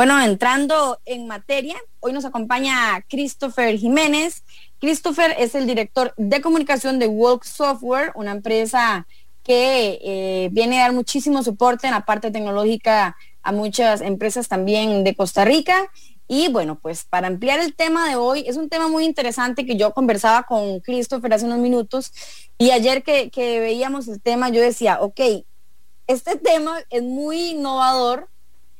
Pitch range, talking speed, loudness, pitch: 220-280 Hz, 155 wpm, -19 LUFS, 245 Hz